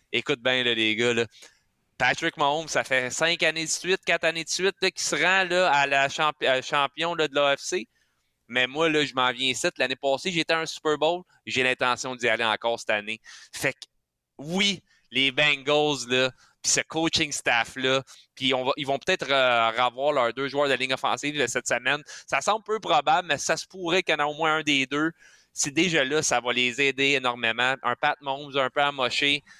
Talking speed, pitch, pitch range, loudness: 215 wpm, 140 Hz, 130-160 Hz, -24 LUFS